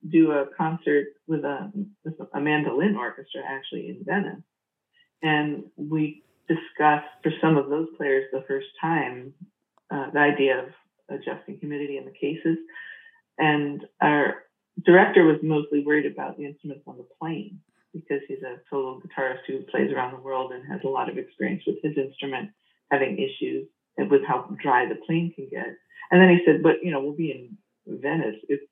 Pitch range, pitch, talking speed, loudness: 140-180 Hz, 155 Hz, 180 wpm, -24 LUFS